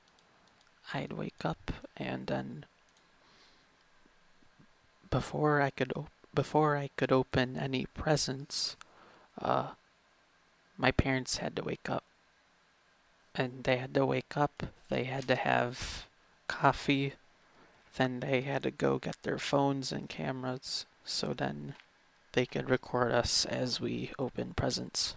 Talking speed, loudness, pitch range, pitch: 125 wpm, -33 LUFS, 100-140 Hz, 130 Hz